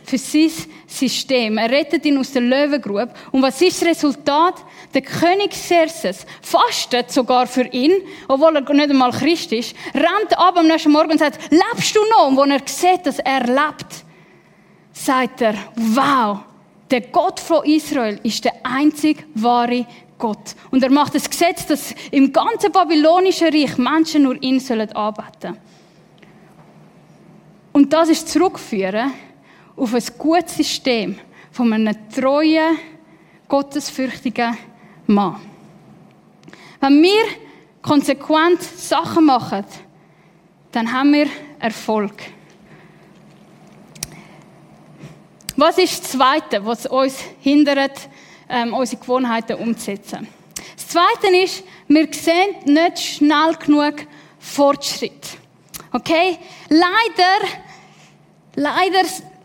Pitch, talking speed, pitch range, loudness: 275 Hz, 115 wpm, 230-320 Hz, -17 LUFS